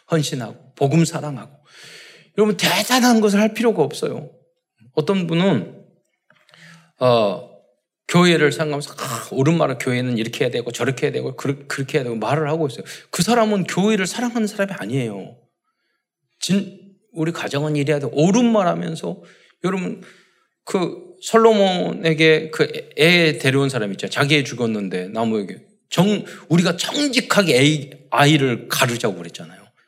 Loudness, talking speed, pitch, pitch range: -19 LUFS, 325 characters per minute, 160 Hz, 140-205 Hz